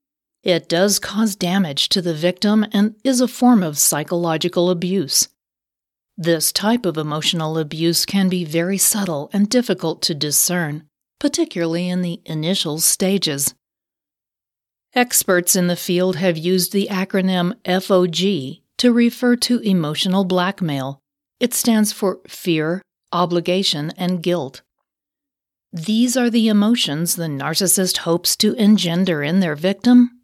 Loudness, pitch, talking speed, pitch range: -18 LUFS, 180 Hz, 130 wpm, 165-210 Hz